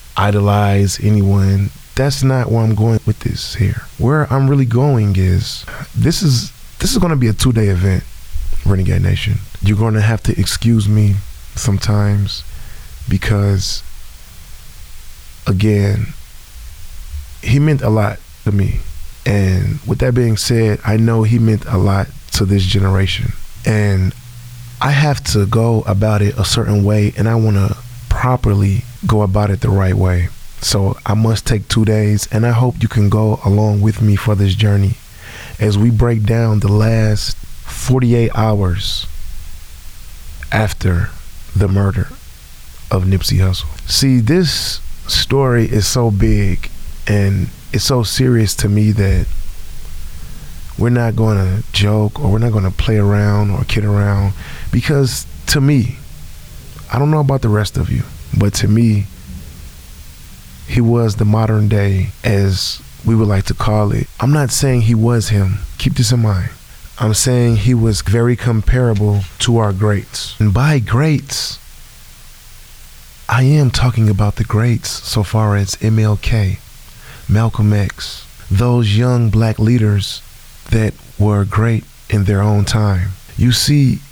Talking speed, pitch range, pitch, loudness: 150 wpm, 95-115 Hz, 105 Hz, -15 LUFS